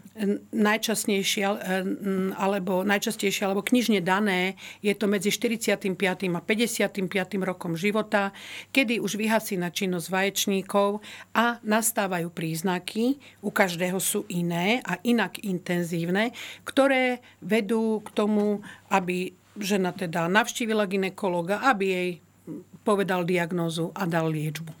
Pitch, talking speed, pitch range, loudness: 200 Hz, 110 wpm, 185-215 Hz, -26 LUFS